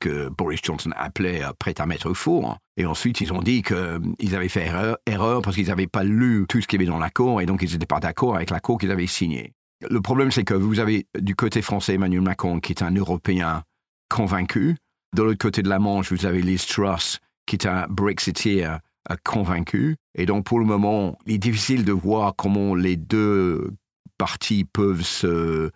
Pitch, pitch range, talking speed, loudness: 100 Hz, 90-110 Hz, 205 wpm, -23 LUFS